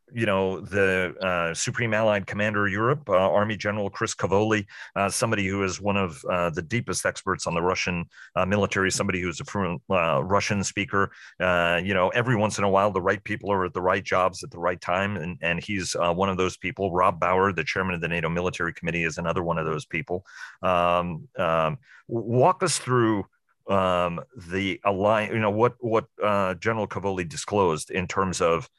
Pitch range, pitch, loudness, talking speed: 90-105 Hz, 95 Hz, -25 LUFS, 205 wpm